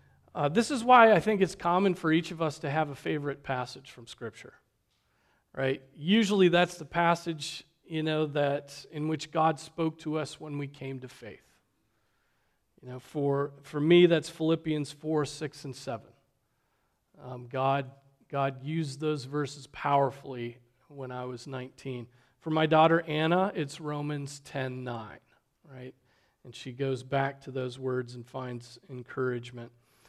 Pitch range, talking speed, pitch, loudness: 130-160 Hz, 160 wpm, 140 Hz, -29 LUFS